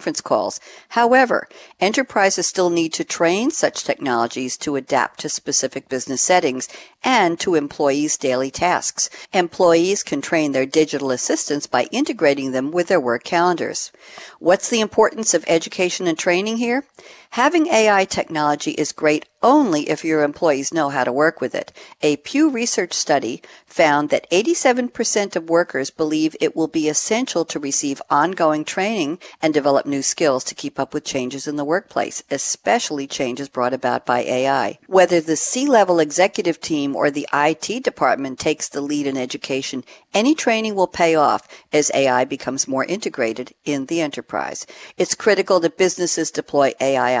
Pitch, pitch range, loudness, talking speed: 155 Hz, 140-190 Hz, -19 LUFS, 160 wpm